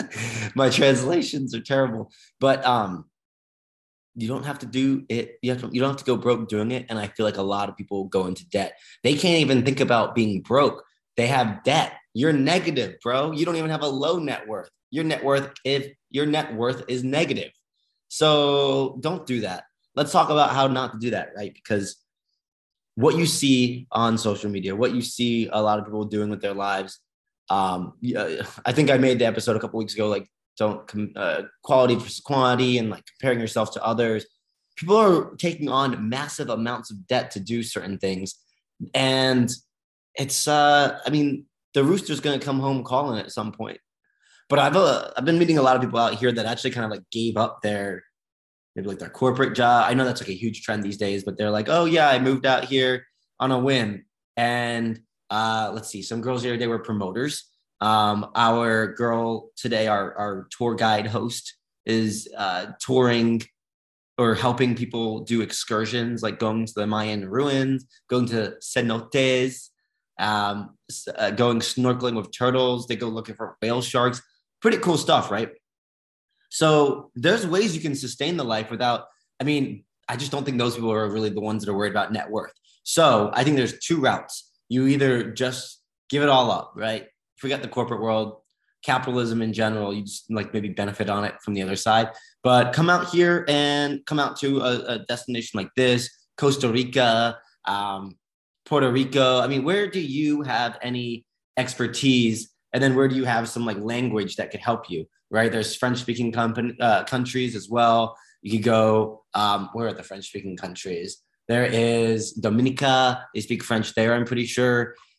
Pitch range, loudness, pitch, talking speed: 110-130 Hz, -23 LUFS, 120 Hz, 195 wpm